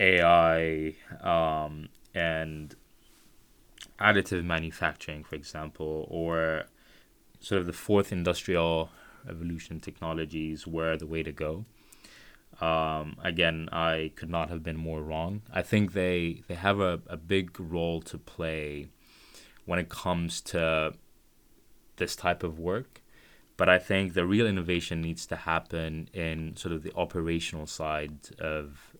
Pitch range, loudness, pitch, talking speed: 80-90 Hz, -30 LUFS, 80 Hz, 130 wpm